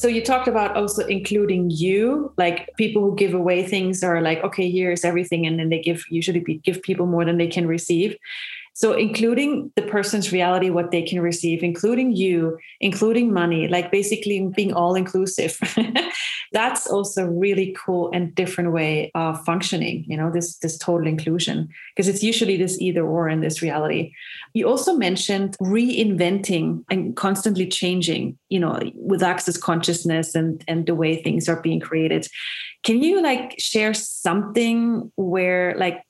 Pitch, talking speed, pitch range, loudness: 185 Hz, 165 wpm, 170-210 Hz, -21 LUFS